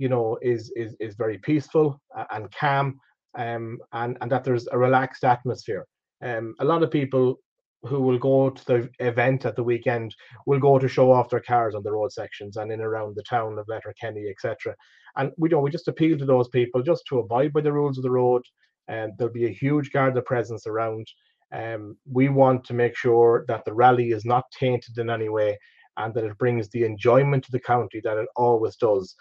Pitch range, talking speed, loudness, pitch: 115-135 Hz, 220 wpm, -24 LUFS, 125 Hz